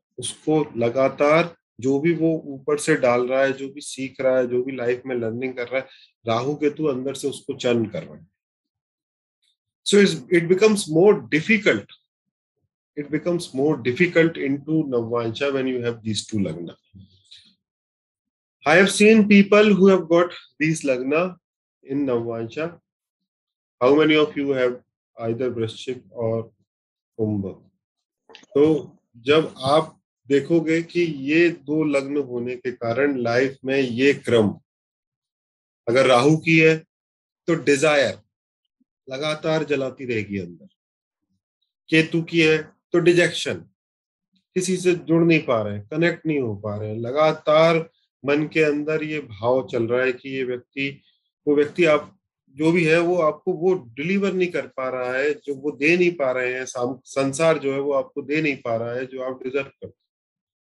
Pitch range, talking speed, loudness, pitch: 125-160 Hz, 155 wpm, -21 LUFS, 140 Hz